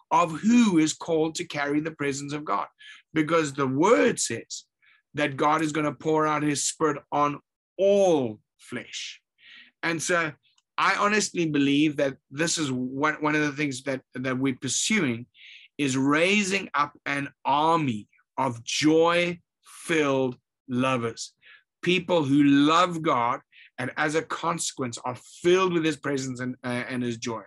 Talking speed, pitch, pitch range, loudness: 150 wpm, 145 Hz, 130-165 Hz, -25 LUFS